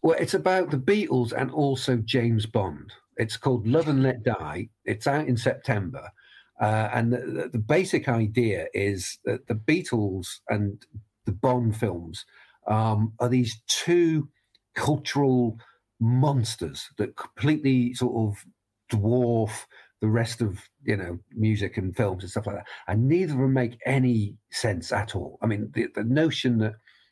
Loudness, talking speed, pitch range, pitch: -26 LUFS, 155 wpm, 105-130 Hz, 115 Hz